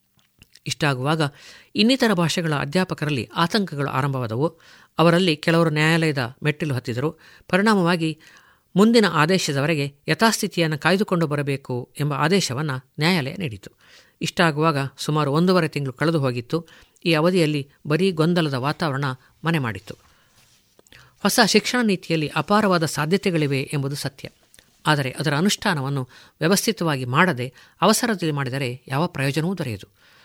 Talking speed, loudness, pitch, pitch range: 100 wpm, -21 LUFS, 160 Hz, 140-180 Hz